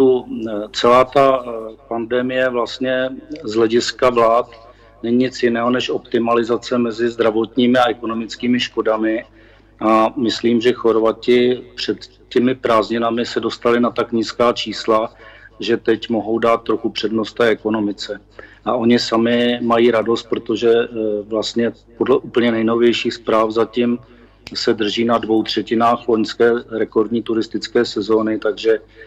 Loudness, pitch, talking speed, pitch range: -17 LUFS, 115 Hz, 125 wpm, 110-120 Hz